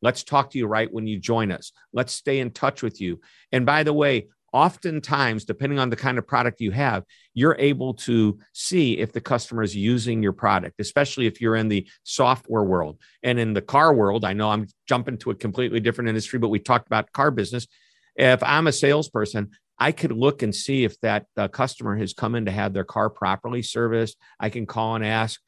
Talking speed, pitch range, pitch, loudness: 215 wpm, 105-130 Hz, 115 Hz, -23 LUFS